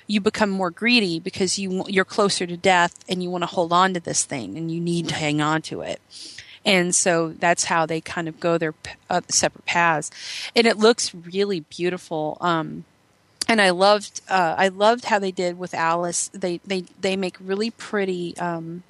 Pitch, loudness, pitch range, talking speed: 180 Hz, -22 LUFS, 170-195 Hz, 200 wpm